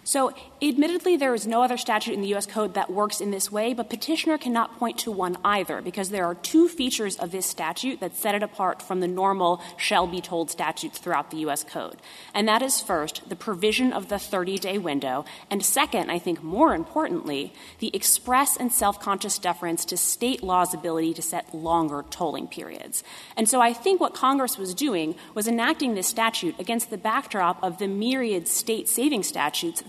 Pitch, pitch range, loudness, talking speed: 205 Hz, 180-245 Hz, -25 LUFS, 195 wpm